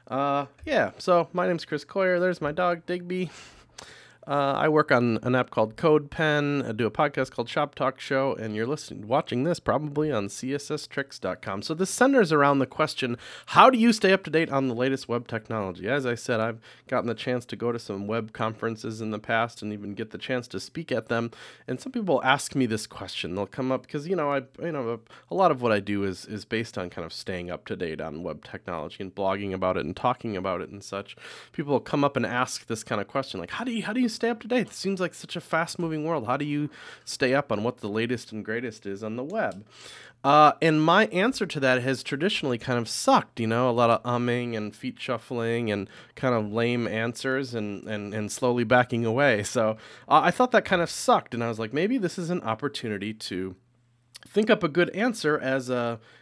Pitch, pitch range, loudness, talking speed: 125 Hz, 110-150 Hz, -26 LUFS, 240 wpm